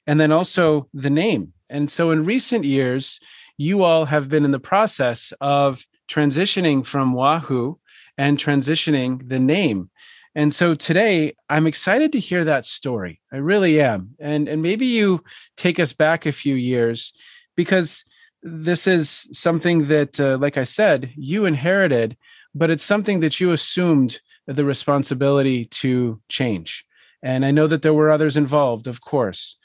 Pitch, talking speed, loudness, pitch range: 150 Hz, 160 wpm, -19 LUFS, 135-175 Hz